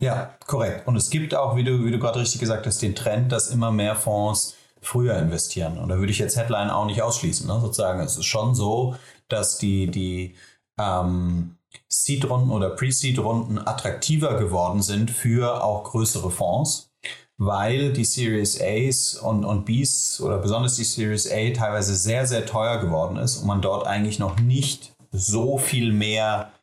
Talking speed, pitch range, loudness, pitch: 175 wpm, 100-125 Hz, -23 LUFS, 110 Hz